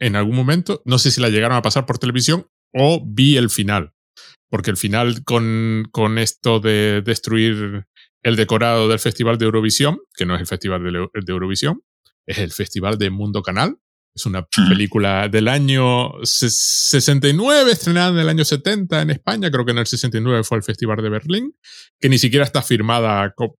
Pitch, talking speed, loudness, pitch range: 115 Hz, 185 wpm, -17 LUFS, 105-135 Hz